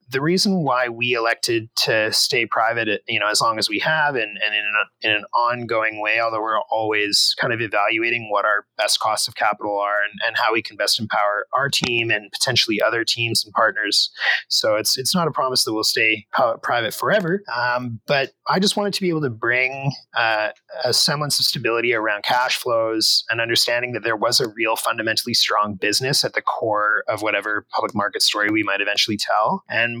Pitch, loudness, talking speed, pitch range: 115 Hz, -19 LUFS, 210 wpm, 105-130 Hz